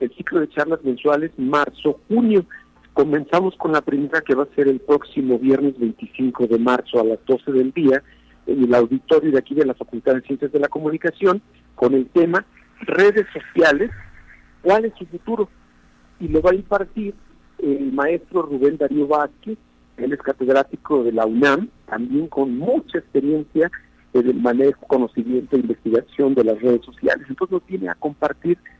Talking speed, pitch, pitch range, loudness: 170 wpm, 140 Hz, 130-165 Hz, -19 LUFS